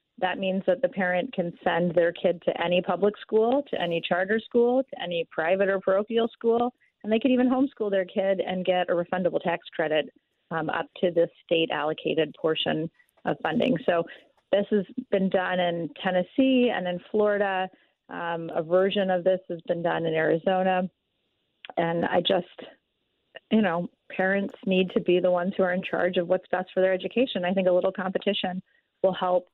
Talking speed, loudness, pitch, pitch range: 190 wpm, -26 LUFS, 185 Hz, 175-210 Hz